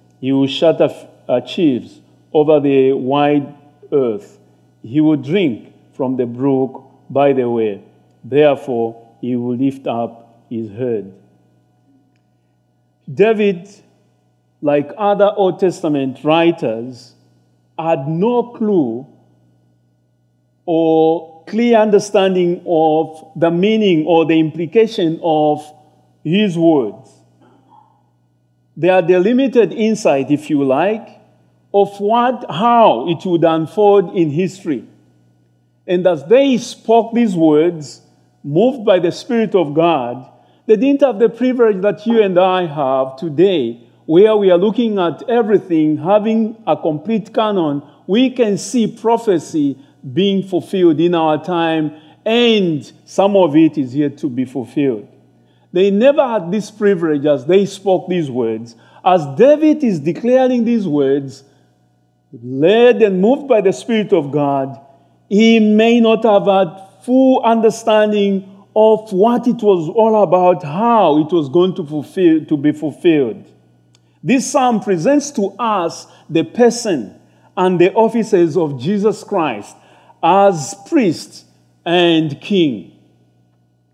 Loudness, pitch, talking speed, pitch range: -15 LUFS, 165 Hz, 125 wpm, 135-210 Hz